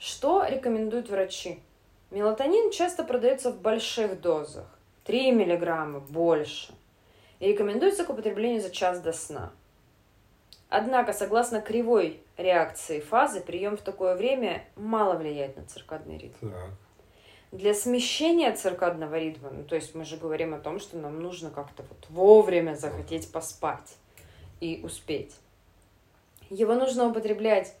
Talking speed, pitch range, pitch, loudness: 125 wpm, 140-220 Hz, 175 Hz, -27 LUFS